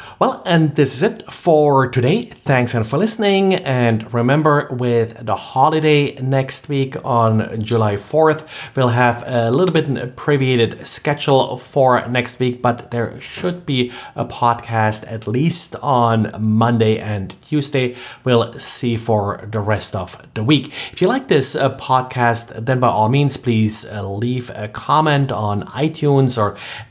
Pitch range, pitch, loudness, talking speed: 115-140 Hz, 125 Hz, -16 LUFS, 155 wpm